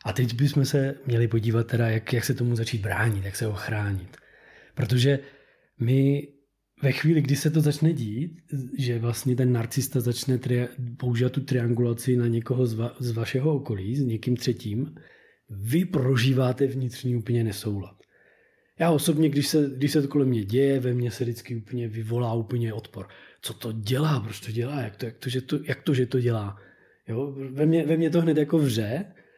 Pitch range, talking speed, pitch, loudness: 115-140 Hz, 190 wpm, 125 Hz, -26 LUFS